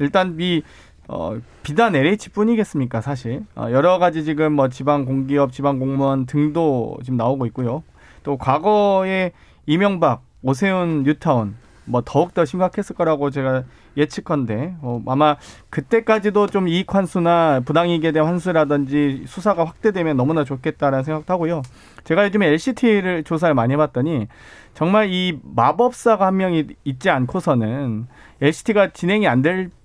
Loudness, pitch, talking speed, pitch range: -19 LUFS, 155 Hz, 325 characters per minute, 135-185 Hz